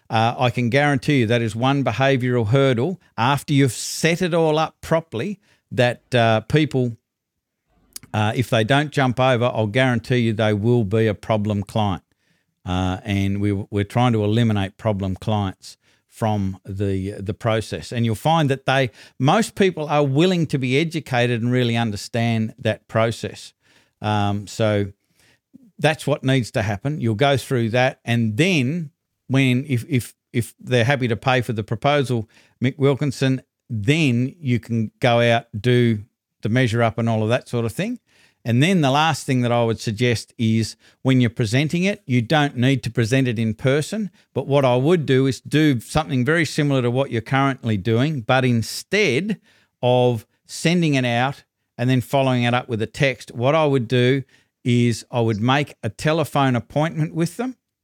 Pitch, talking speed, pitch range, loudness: 125 Hz, 175 wpm, 115-140 Hz, -20 LUFS